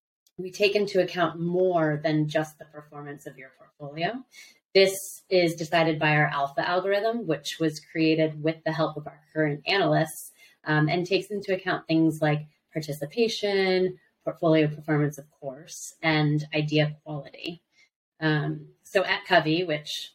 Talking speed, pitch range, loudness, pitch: 145 wpm, 150-185 Hz, -25 LUFS, 160 Hz